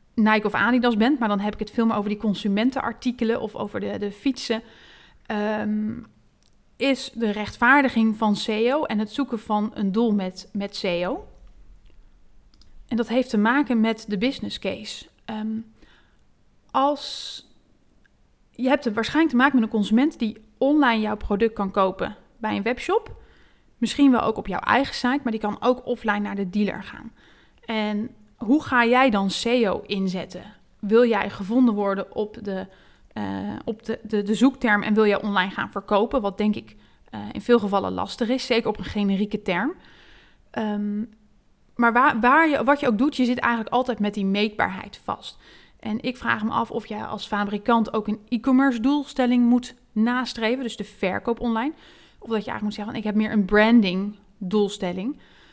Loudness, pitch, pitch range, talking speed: -23 LUFS, 220 Hz, 210-245 Hz, 180 wpm